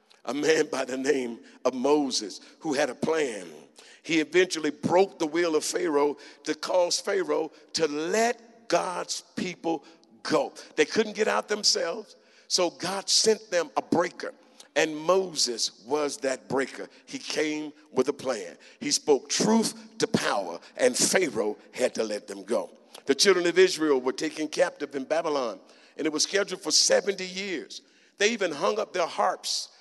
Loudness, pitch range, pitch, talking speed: -26 LUFS, 150-210 Hz, 175 Hz, 165 wpm